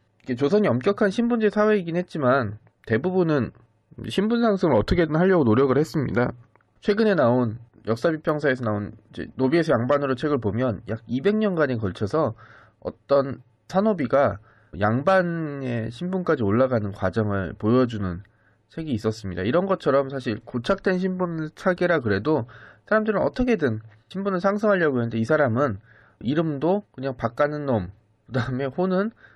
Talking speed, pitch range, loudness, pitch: 330 characters per minute, 110-180 Hz, -23 LUFS, 135 Hz